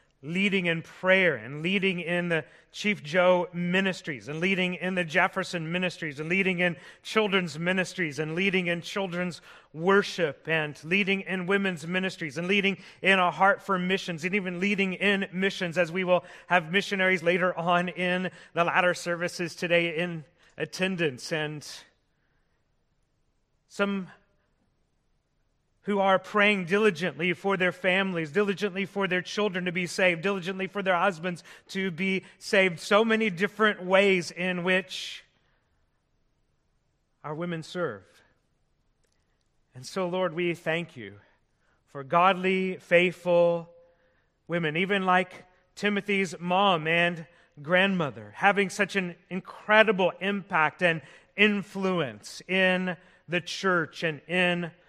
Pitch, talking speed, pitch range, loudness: 180 Hz, 130 wpm, 170-195 Hz, -26 LUFS